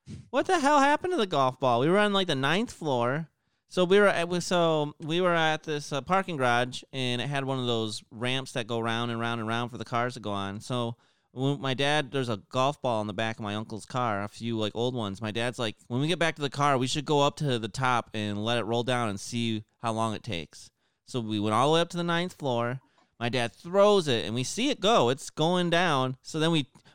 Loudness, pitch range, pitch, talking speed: -28 LUFS, 115-160 Hz, 130 Hz, 270 wpm